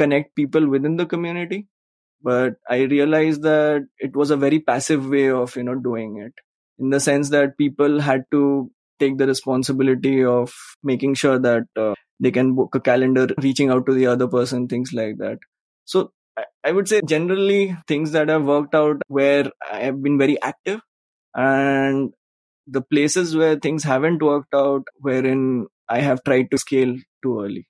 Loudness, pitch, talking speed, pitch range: -20 LUFS, 135 Hz, 175 wpm, 130-150 Hz